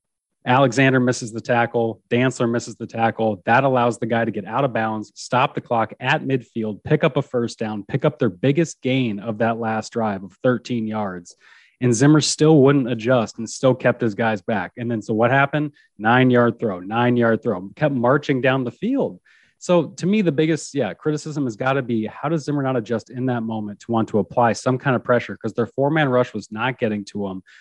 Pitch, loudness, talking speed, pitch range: 120 Hz, -20 LUFS, 220 wpm, 115-140 Hz